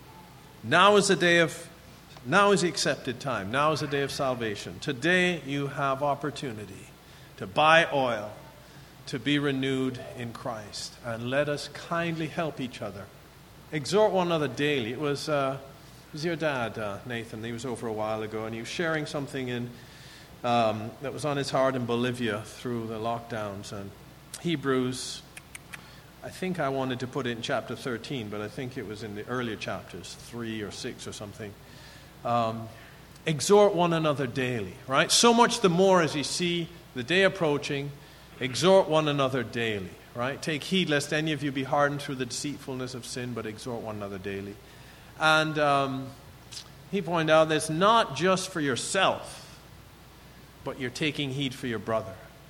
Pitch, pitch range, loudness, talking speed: 140 Hz, 120-155 Hz, -27 LUFS, 175 wpm